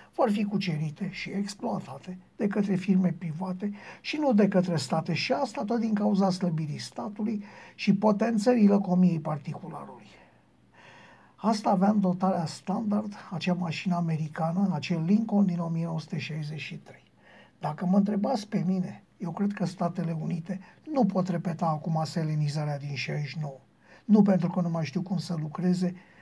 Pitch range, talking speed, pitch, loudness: 165-205 Hz, 145 wpm, 180 Hz, -28 LUFS